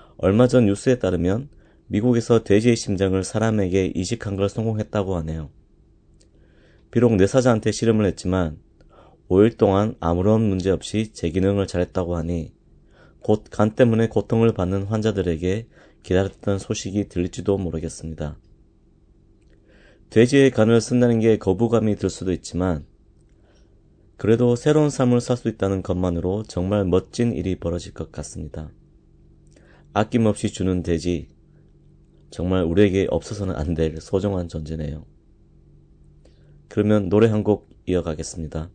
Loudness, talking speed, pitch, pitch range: -21 LUFS, 295 characters per minute, 95 Hz, 90-110 Hz